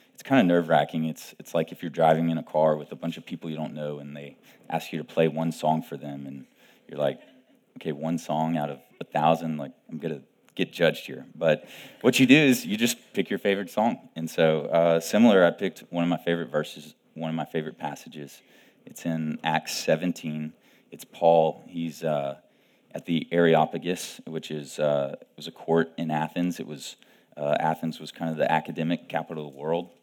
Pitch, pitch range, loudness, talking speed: 80 Hz, 75-85 Hz, -26 LUFS, 220 wpm